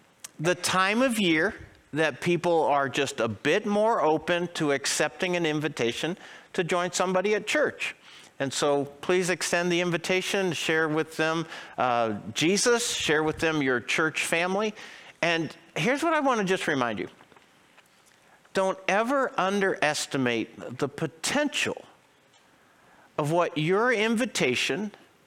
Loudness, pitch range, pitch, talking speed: -26 LUFS, 150-190 Hz, 170 Hz, 135 wpm